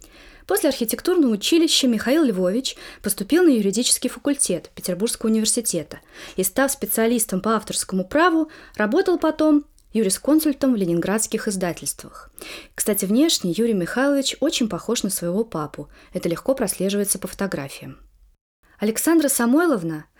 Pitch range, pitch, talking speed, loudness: 190-280 Hz, 225 Hz, 115 wpm, -21 LUFS